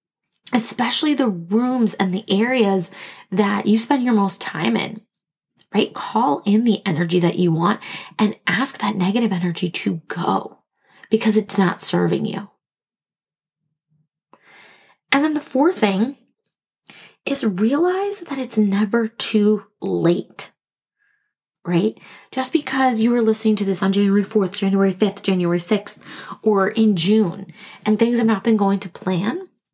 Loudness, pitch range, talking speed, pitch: -19 LUFS, 190-230 Hz, 145 wpm, 210 Hz